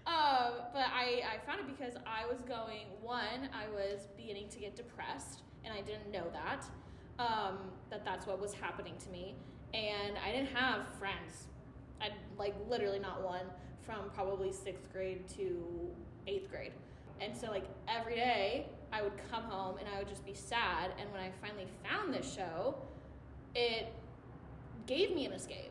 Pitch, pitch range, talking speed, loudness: 210 Hz, 195-245 Hz, 175 wpm, -40 LUFS